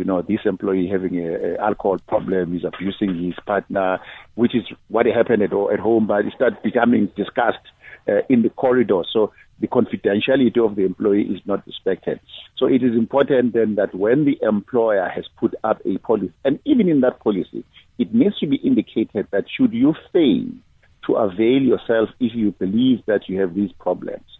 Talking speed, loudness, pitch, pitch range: 190 wpm, -20 LUFS, 110 Hz, 95-135 Hz